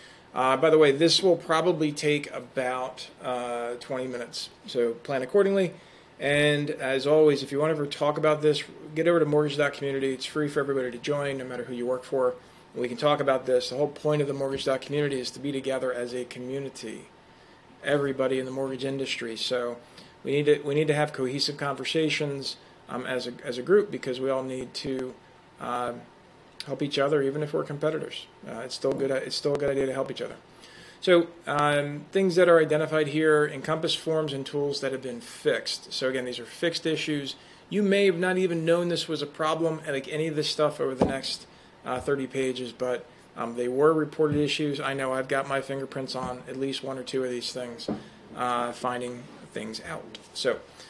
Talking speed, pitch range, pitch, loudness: 210 wpm, 130-150 Hz, 140 Hz, -27 LUFS